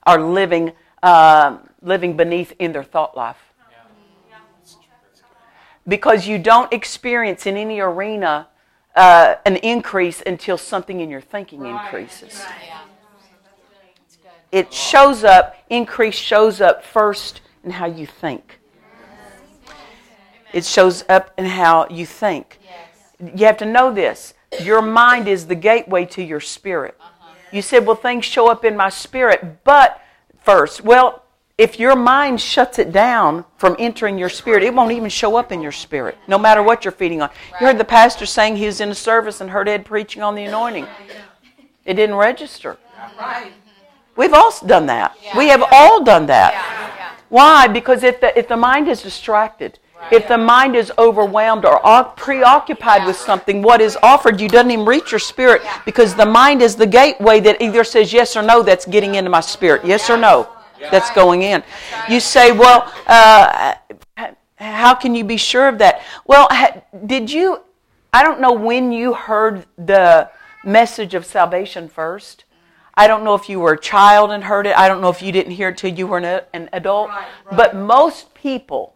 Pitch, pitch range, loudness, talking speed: 210 Hz, 185-235 Hz, -12 LUFS, 170 wpm